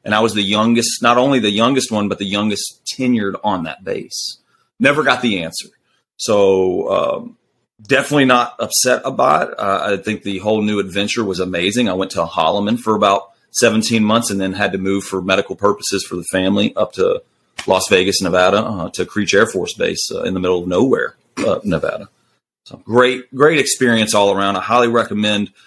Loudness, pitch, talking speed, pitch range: -16 LUFS, 105 Hz, 195 wpm, 100-120 Hz